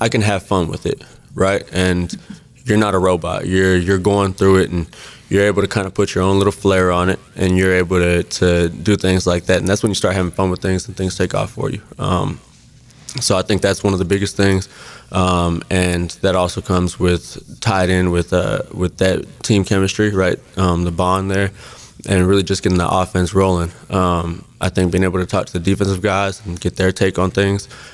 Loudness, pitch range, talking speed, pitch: -17 LUFS, 90-100 Hz, 230 wpm, 95 Hz